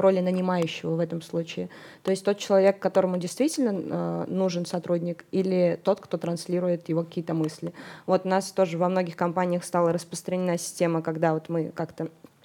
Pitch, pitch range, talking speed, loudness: 175 Hz, 165-185 Hz, 170 wpm, -27 LUFS